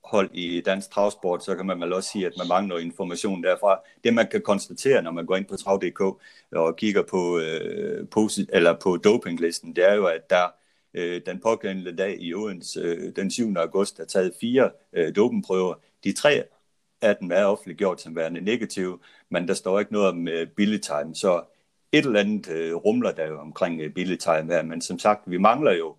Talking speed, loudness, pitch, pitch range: 200 wpm, -24 LUFS, 90 Hz, 85-100 Hz